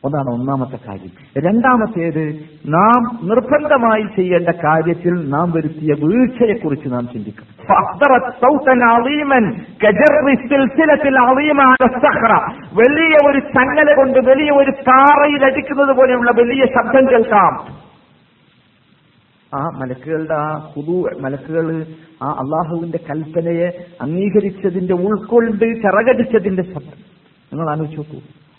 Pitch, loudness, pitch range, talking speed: 200 Hz, -14 LUFS, 155-255 Hz, 85 wpm